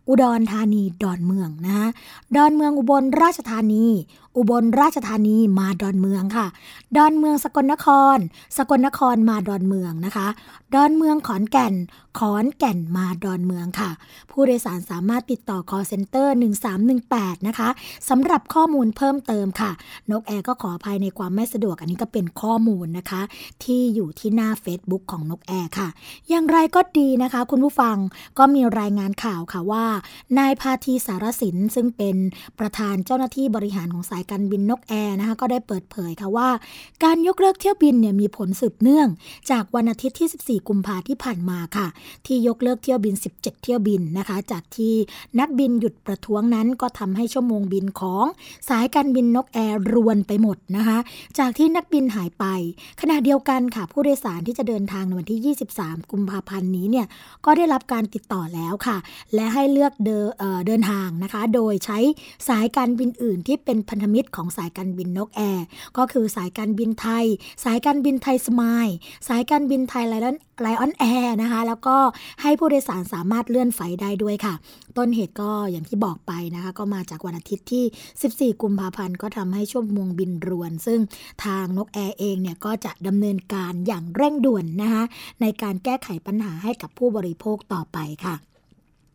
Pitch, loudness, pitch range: 220 Hz, -21 LUFS, 195-250 Hz